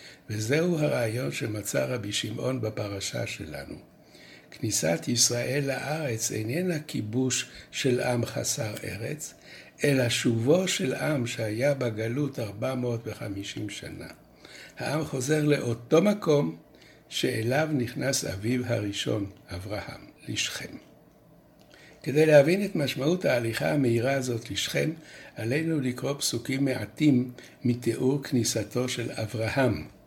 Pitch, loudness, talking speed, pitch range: 125 Hz, -27 LUFS, 100 wpm, 115-145 Hz